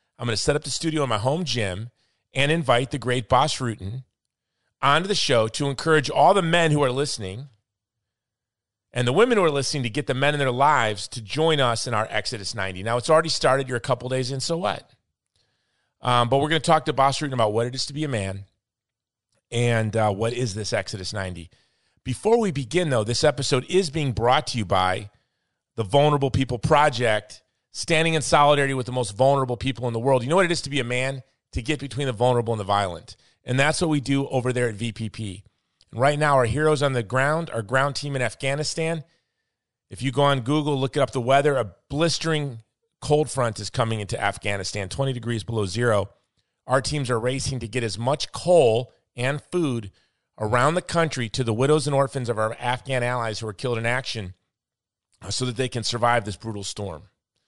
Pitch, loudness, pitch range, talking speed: 125 Hz, -23 LUFS, 115-145 Hz, 215 wpm